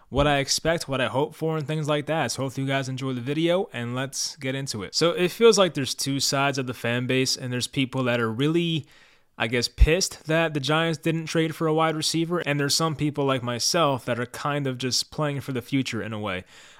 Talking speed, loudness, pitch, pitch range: 250 wpm, -24 LUFS, 140 Hz, 130-160 Hz